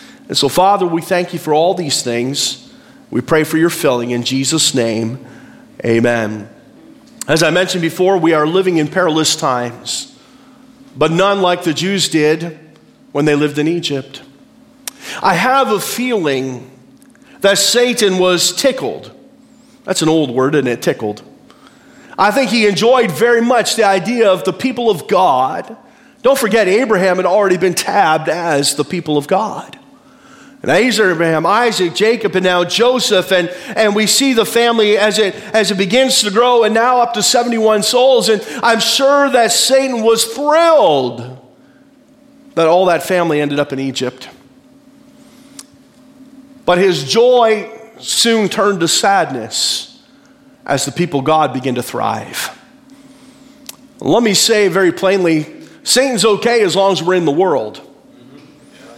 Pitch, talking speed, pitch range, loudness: 205 Hz, 155 wpm, 160-255 Hz, -13 LUFS